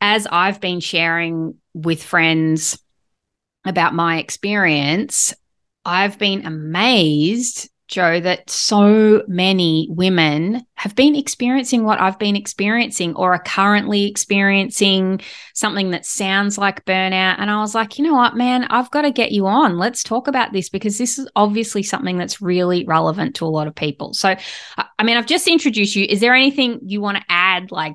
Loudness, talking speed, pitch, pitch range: -17 LUFS, 170 wpm, 195 Hz, 175-225 Hz